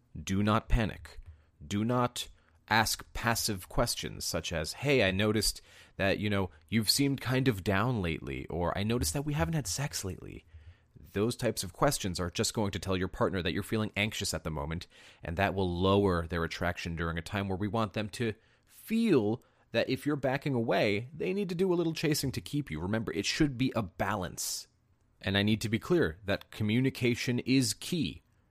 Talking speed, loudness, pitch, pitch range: 200 wpm, -31 LUFS, 105 Hz, 90-120 Hz